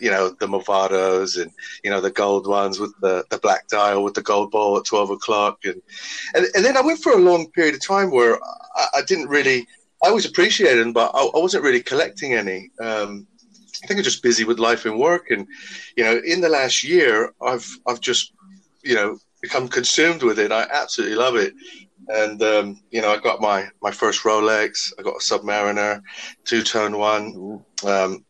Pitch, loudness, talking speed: 115 Hz, -19 LUFS, 205 wpm